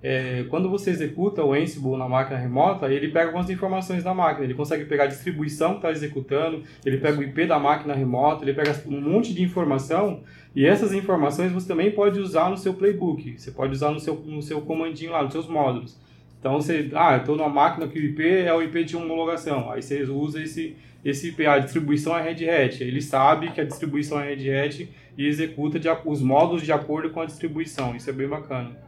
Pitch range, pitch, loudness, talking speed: 140-165 Hz, 155 Hz, -24 LUFS, 215 wpm